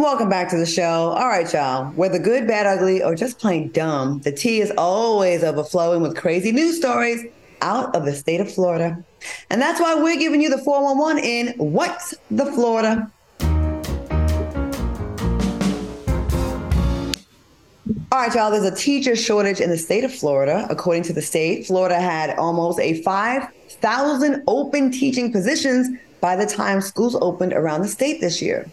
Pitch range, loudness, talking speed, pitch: 165-250 Hz, -20 LUFS, 160 wpm, 195 Hz